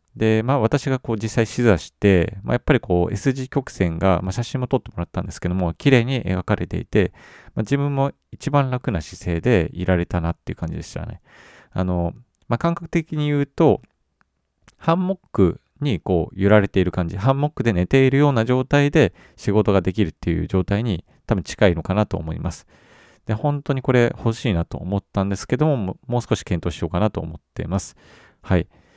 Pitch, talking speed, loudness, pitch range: 110 Hz, 390 characters per minute, -21 LUFS, 90-130 Hz